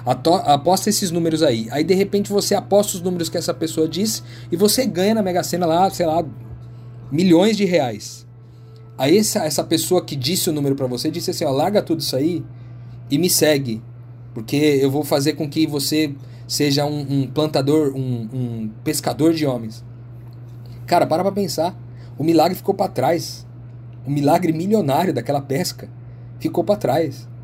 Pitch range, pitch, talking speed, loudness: 120-170 Hz, 145 Hz, 175 wpm, -19 LUFS